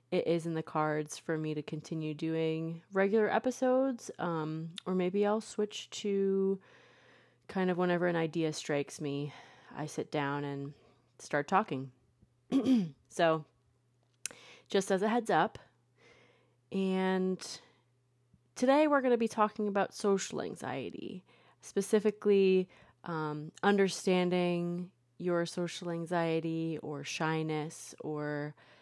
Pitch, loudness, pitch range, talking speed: 170 Hz, -33 LUFS, 150-195 Hz, 115 wpm